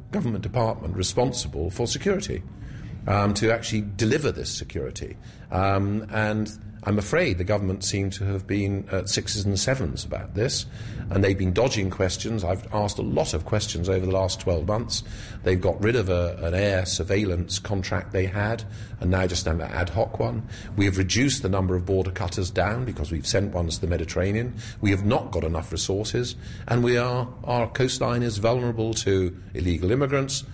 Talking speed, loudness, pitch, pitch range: 185 wpm, -25 LUFS, 100 Hz, 95-115 Hz